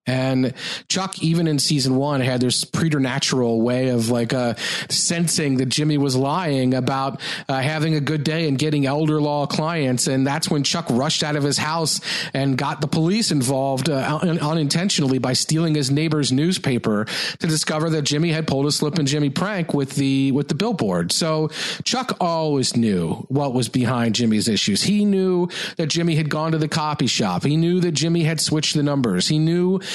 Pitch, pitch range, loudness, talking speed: 150 Hz, 135-165 Hz, -20 LUFS, 190 wpm